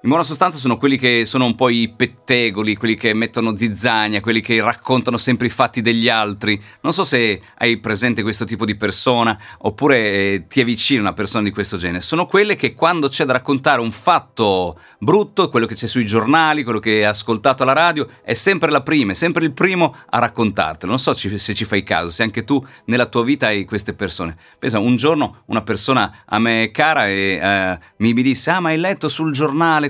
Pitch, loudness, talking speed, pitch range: 115 Hz, -17 LUFS, 210 wpm, 105-135 Hz